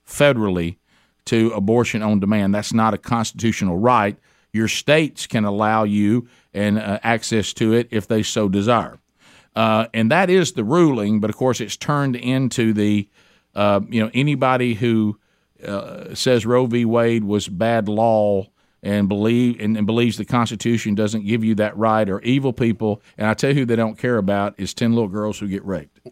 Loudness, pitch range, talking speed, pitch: -19 LUFS, 105-120 Hz, 185 wpm, 110 Hz